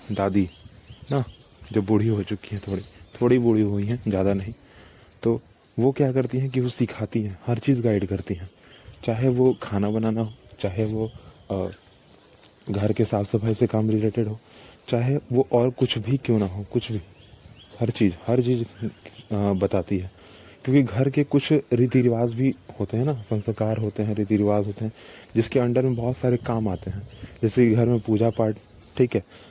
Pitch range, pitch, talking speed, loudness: 100-120 Hz, 110 Hz, 185 wpm, -24 LUFS